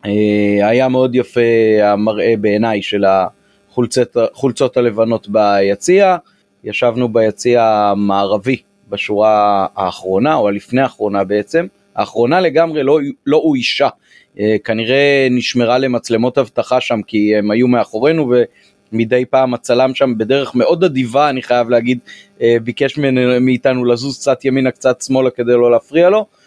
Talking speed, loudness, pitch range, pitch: 120 wpm, -14 LUFS, 105-130 Hz, 120 Hz